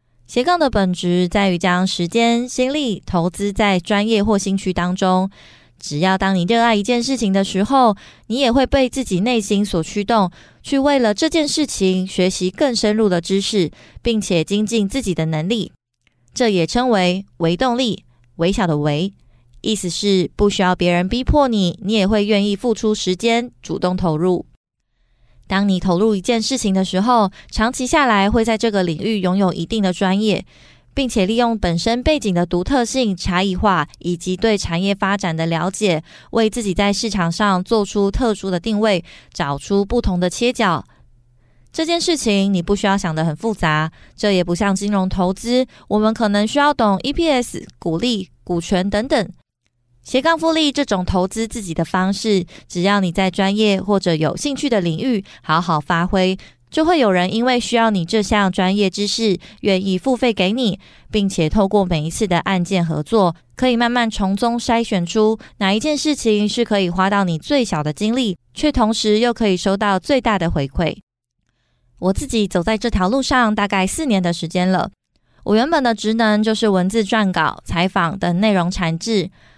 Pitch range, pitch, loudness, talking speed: 180-230 Hz, 200 Hz, -18 LUFS, 265 characters per minute